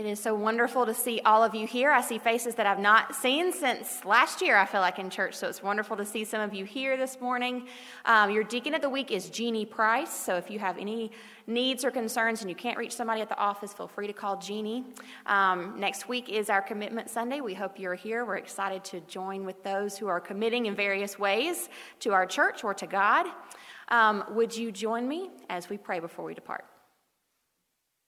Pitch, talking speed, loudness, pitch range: 220 Hz, 225 wpm, -28 LUFS, 200-240 Hz